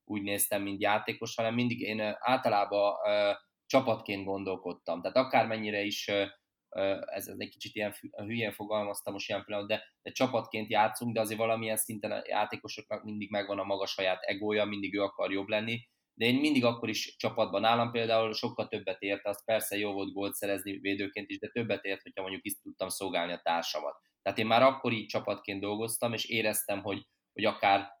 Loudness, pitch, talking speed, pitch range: -32 LUFS, 105 Hz, 190 wpm, 100-115 Hz